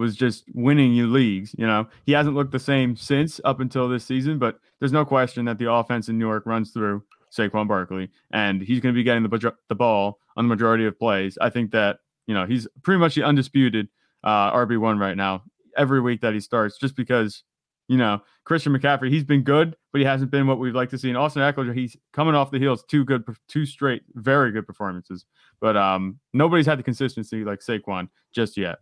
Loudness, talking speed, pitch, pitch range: -22 LUFS, 225 wpm, 120 Hz, 110-135 Hz